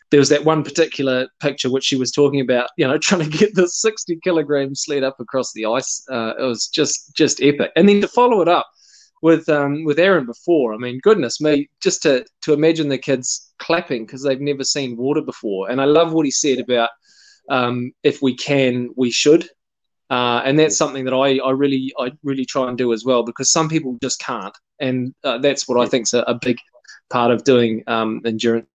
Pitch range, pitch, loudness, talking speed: 125-155 Hz, 135 Hz, -18 LUFS, 220 wpm